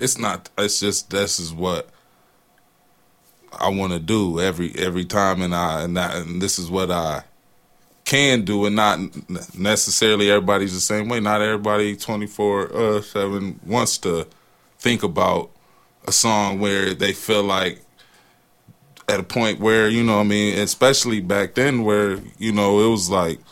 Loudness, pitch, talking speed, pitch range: -20 LUFS, 100 Hz, 165 wpm, 95-105 Hz